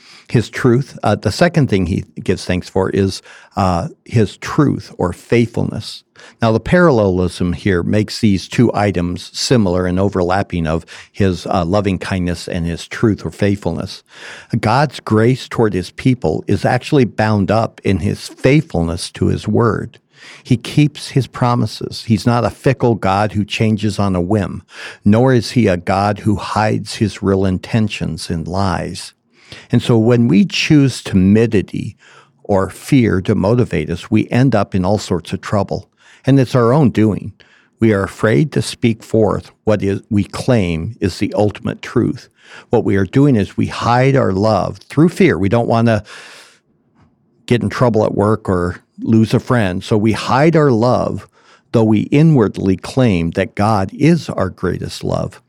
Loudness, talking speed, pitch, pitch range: -15 LUFS, 170 wpm, 105 Hz, 95-120 Hz